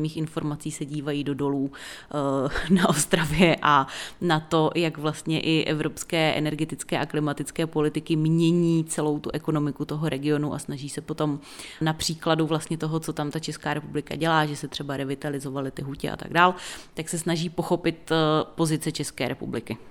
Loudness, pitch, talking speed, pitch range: -26 LUFS, 155 Hz, 165 wpm, 150-160 Hz